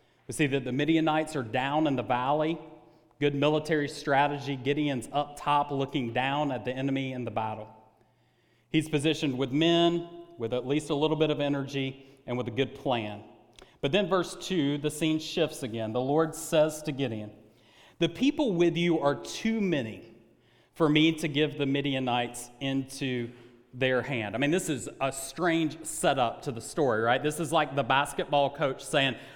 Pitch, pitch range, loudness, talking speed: 140 Hz, 125-155 Hz, -28 LUFS, 180 wpm